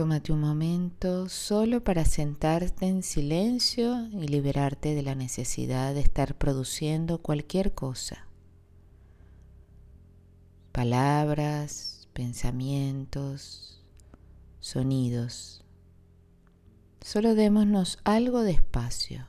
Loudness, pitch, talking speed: -28 LUFS, 135 Hz, 80 wpm